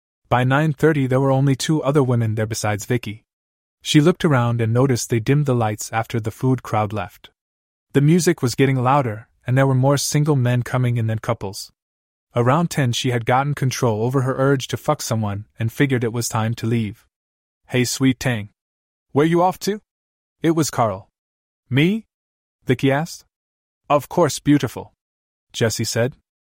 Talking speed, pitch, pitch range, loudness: 175 wpm, 125 Hz, 110-140 Hz, -20 LUFS